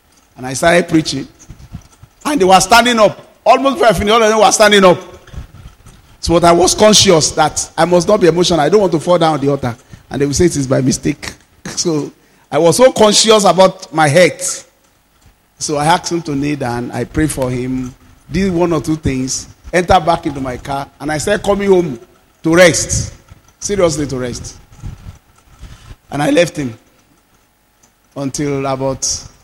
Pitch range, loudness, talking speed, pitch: 130-180 Hz, -12 LUFS, 185 wpm, 155 Hz